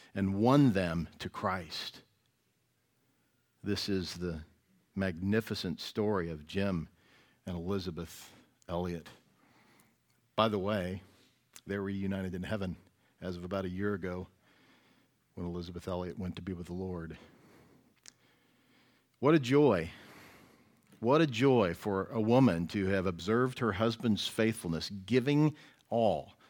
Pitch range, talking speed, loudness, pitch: 90-110 Hz, 125 wpm, -33 LUFS, 95 Hz